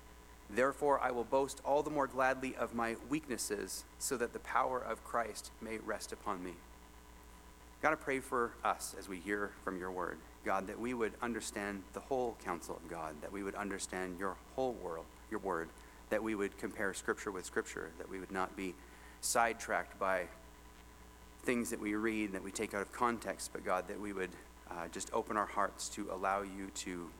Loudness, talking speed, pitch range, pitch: -39 LUFS, 200 wpm, 80-115 Hz, 100 Hz